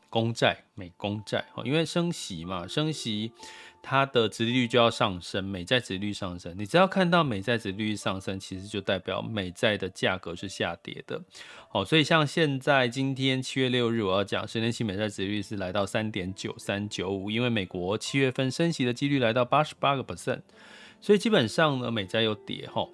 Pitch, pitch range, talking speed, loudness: 115 Hz, 100-135 Hz, 320 characters per minute, -28 LUFS